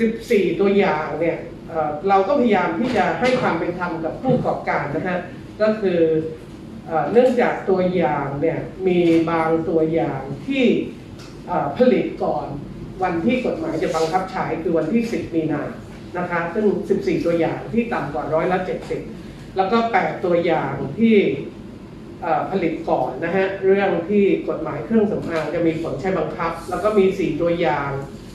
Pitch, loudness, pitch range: 170 Hz, -20 LUFS, 160-195 Hz